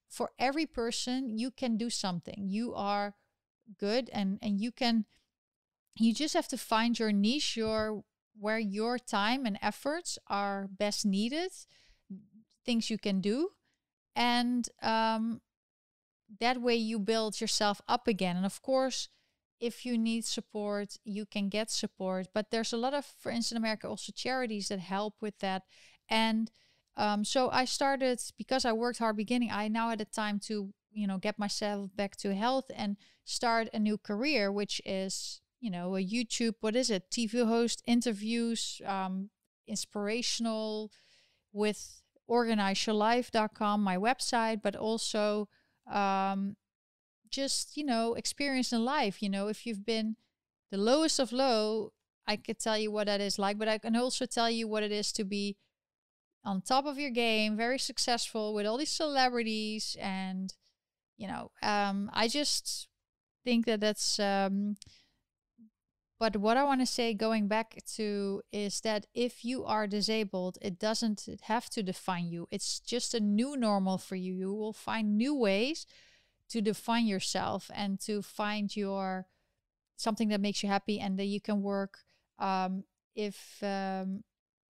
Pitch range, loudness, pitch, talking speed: 205-235 Hz, -32 LUFS, 220 Hz, 160 wpm